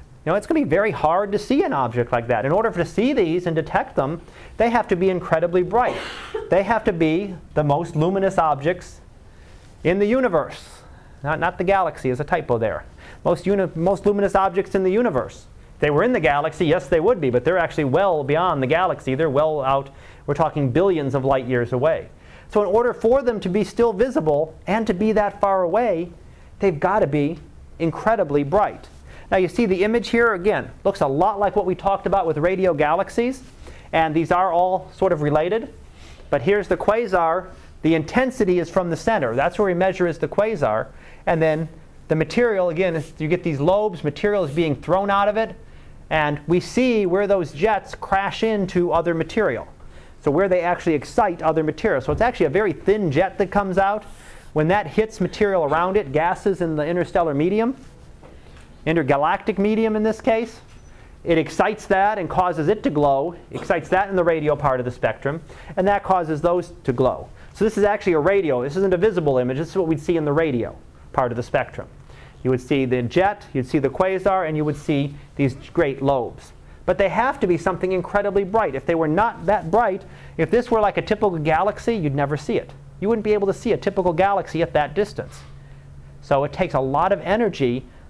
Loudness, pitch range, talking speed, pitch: -21 LUFS, 150-200 Hz, 210 wpm, 180 Hz